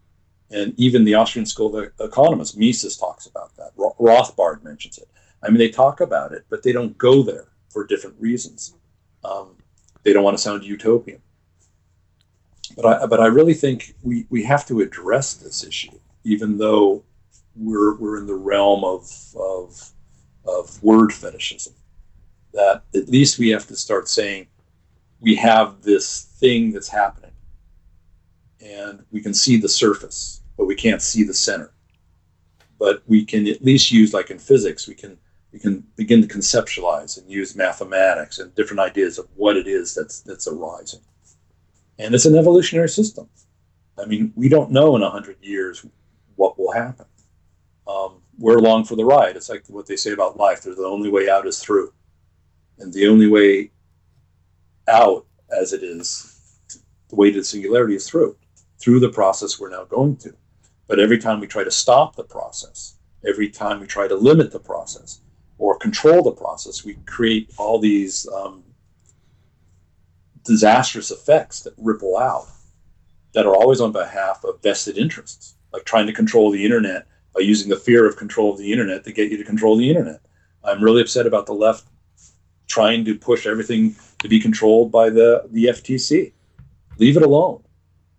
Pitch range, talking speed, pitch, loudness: 90-115 Hz, 175 wpm, 105 Hz, -17 LUFS